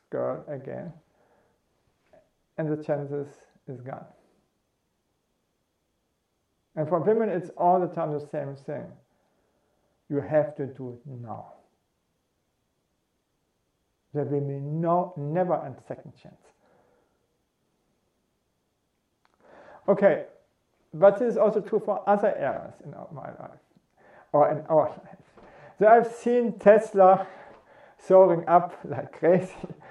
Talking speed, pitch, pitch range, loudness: 110 wpm, 165 Hz, 145-195 Hz, -24 LUFS